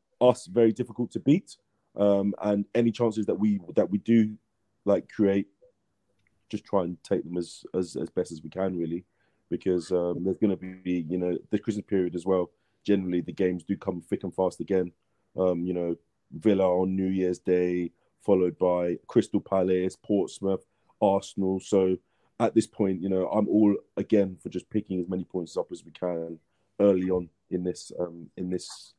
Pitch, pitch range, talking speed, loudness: 95 Hz, 90-105 Hz, 185 wpm, -28 LUFS